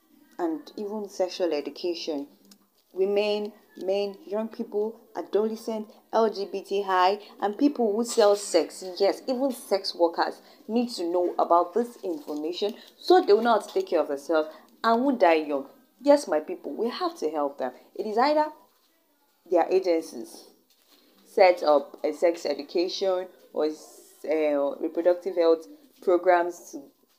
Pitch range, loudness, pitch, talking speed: 170-230 Hz, -26 LUFS, 195 Hz, 135 wpm